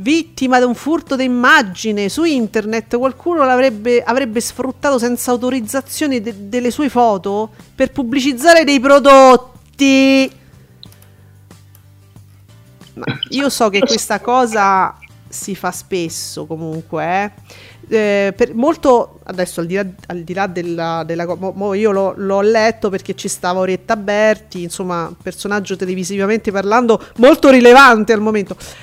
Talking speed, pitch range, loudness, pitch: 130 wpm, 185-255 Hz, -14 LUFS, 220 Hz